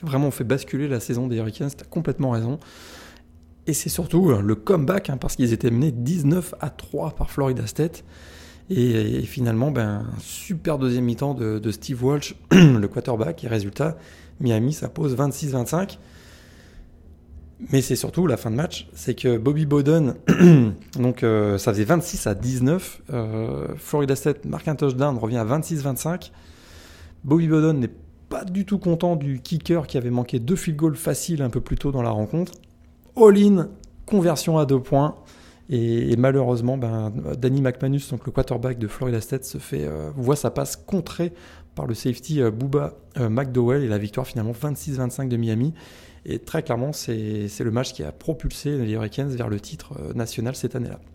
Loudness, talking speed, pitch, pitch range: -23 LUFS, 180 wpm, 130 Hz, 115-150 Hz